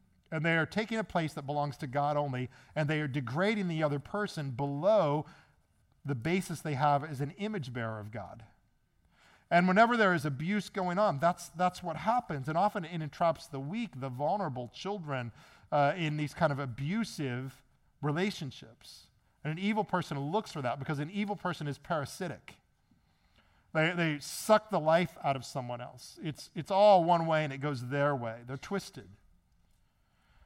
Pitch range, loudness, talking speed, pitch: 135-180 Hz, -32 LUFS, 175 wpm, 150 Hz